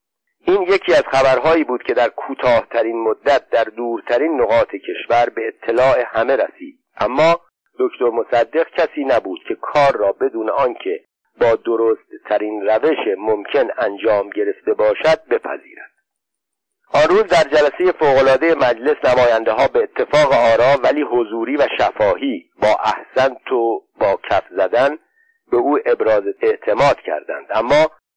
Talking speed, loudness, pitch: 130 wpm, -16 LUFS, 340 Hz